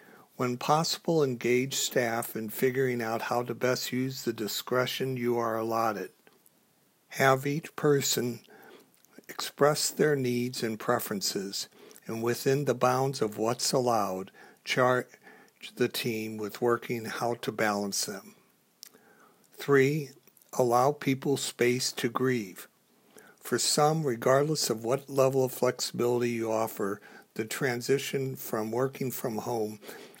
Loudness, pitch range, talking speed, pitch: -29 LUFS, 115-135 Hz, 125 wpm, 125 Hz